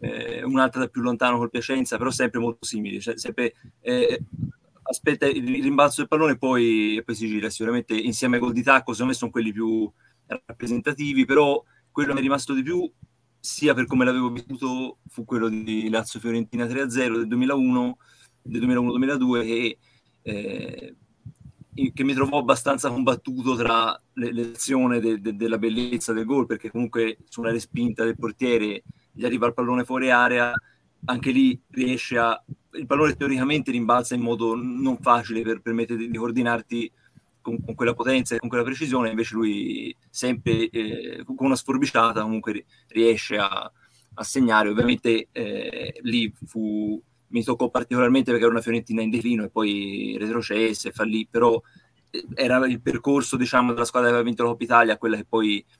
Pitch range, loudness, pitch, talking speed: 115-130 Hz, -23 LUFS, 120 Hz, 165 wpm